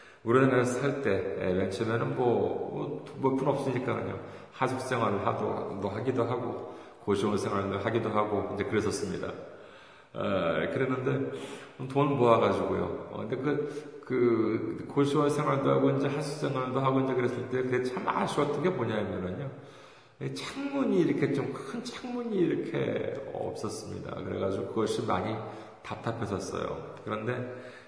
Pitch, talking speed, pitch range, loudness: 125 Hz, 300 characters per minute, 105-135 Hz, -30 LUFS